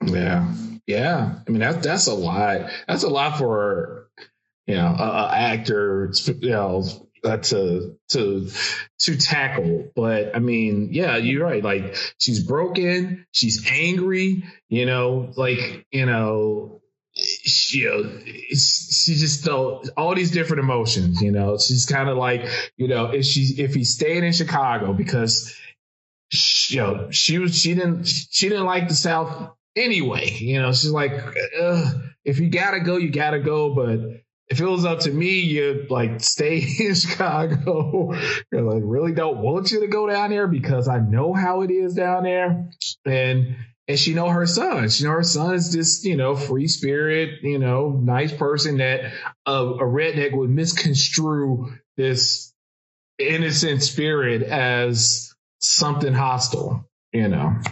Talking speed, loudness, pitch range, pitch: 155 wpm, -20 LUFS, 125-170 Hz, 140 Hz